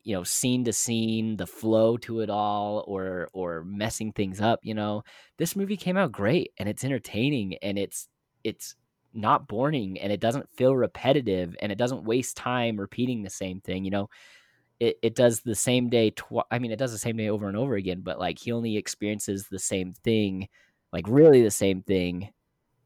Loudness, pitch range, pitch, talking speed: -27 LUFS, 100-120 Hz, 110 Hz, 200 wpm